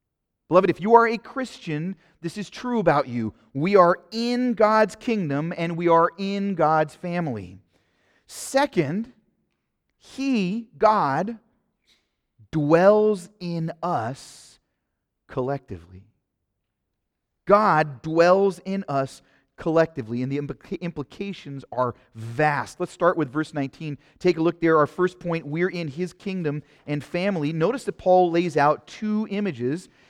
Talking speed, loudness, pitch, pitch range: 130 wpm, -23 LUFS, 165 Hz, 140-195 Hz